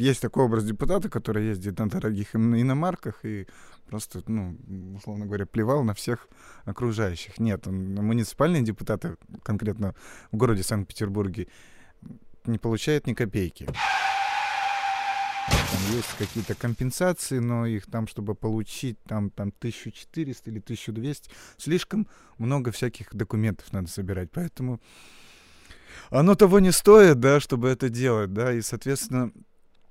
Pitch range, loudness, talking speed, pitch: 105-135 Hz, -25 LUFS, 120 wpm, 115 Hz